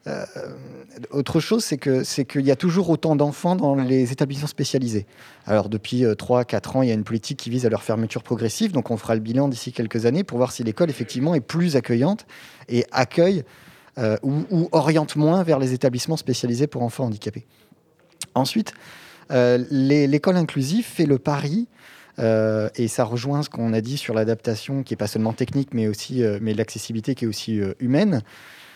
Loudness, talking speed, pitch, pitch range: -22 LUFS, 200 wpm, 130 Hz, 115-150 Hz